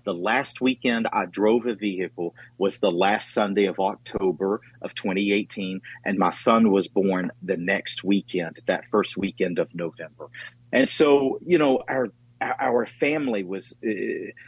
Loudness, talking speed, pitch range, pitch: -24 LUFS, 155 wpm, 95-130 Hz, 115 Hz